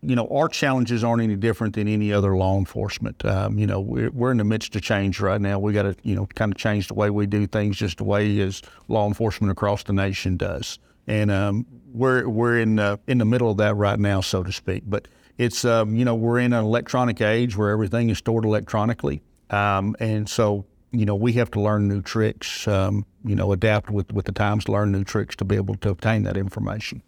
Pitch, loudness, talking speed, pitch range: 105 Hz, -23 LUFS, 235 wpm, 100-115 Hz